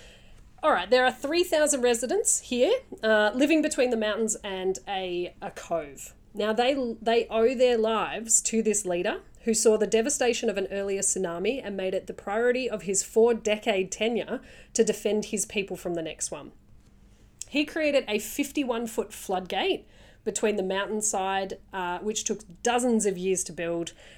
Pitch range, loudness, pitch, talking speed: 195-245 Hz, -26 LUFS, 220 Hz, 170 wpm